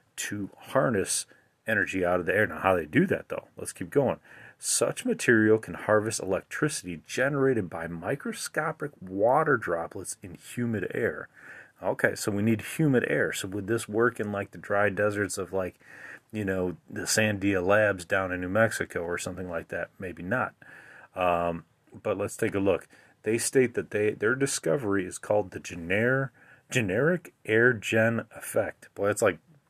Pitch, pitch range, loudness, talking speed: 105 Hz, 90-115 Hz, -28 LUFS, 170 wpm